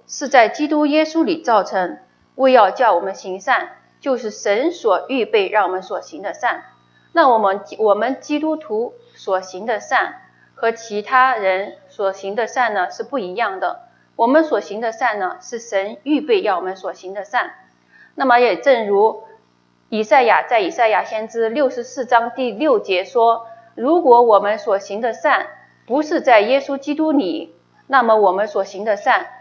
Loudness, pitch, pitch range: -17 LUFS, 235 Hz, 205-295 Hz